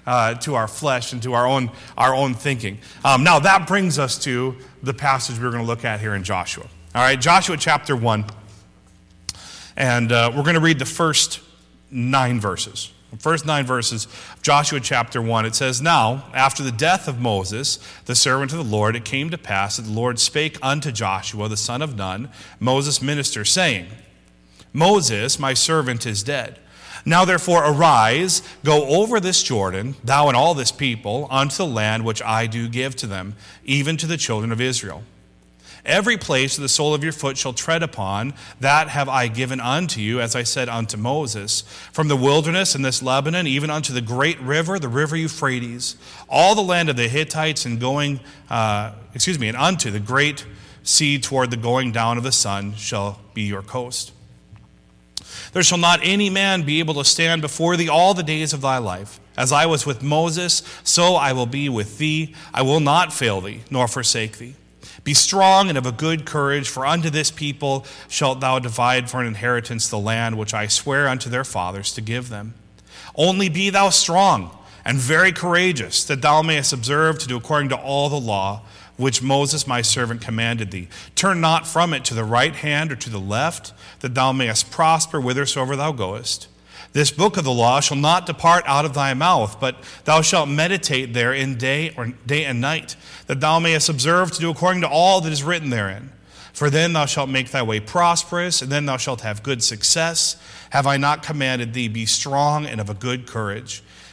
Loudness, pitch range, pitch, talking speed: -19 LUFS, 115-155 Hz, 130 Hz, 200 wpm